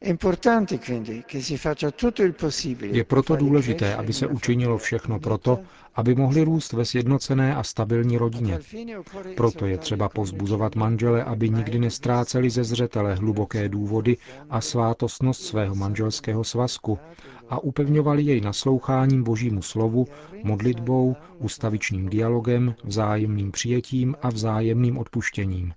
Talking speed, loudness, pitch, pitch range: 110 wpm, -24 LUFS, 120 Hz, 110-135 Hz